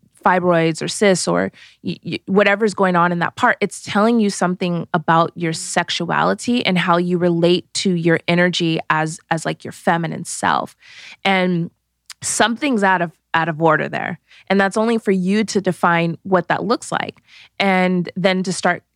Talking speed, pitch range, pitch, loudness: 175 wpm, 170-195 Hz, 180 Hz, -18 LUFS